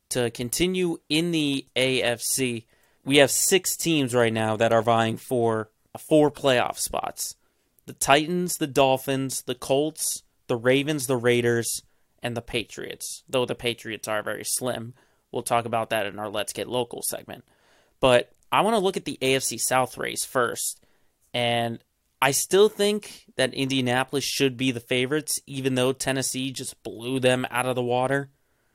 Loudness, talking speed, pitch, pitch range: -24 LUFS, 165 wpm, 130 Hz, 120-140 Hz